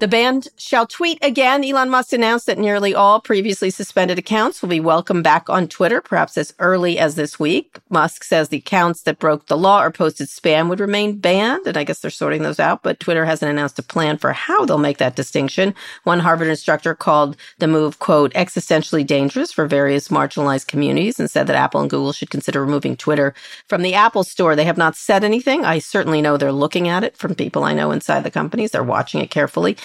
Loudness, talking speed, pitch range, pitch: -17 LUFS, 220 wpm, 150-205 Hz, 165 Hz